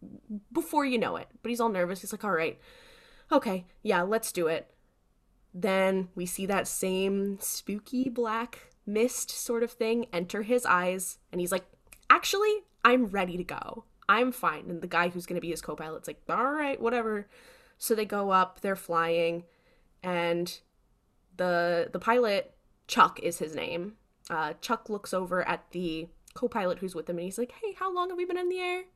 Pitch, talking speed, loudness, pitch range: 200 Hz, 180 wpm, -29 LUFS, 180-240 Hz